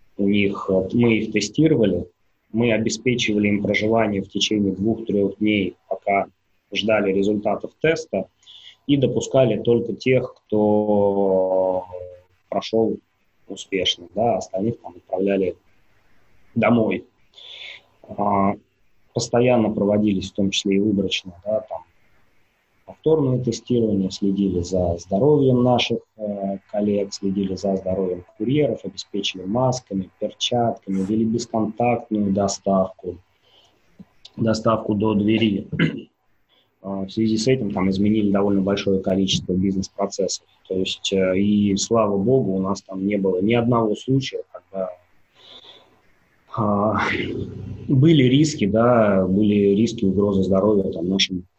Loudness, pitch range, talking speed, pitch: -21 LUFS, 95-115 Hz, 110 wpm, 100 Hz